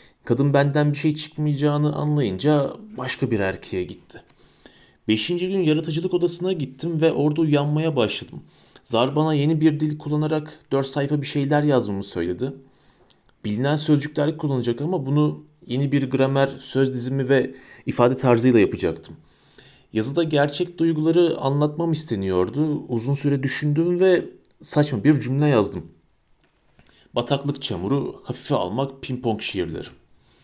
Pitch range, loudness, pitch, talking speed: 135-155 Hz, -22 LUFS, 145 Hz, 125 wpm